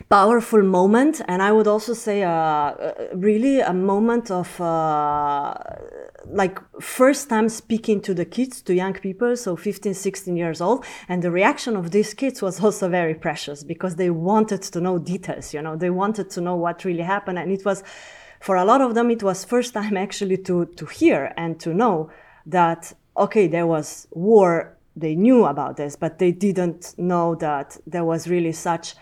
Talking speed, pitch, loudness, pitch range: 185 wpm, 190 Hz, -21 LUFS, 170-215 Hz